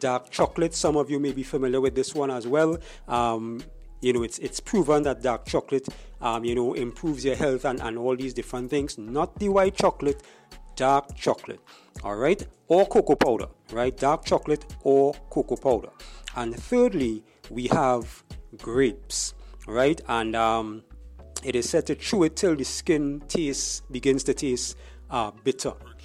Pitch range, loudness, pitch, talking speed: 120-145 Hz, -26 LUFS, 130 Hz, 170 wpm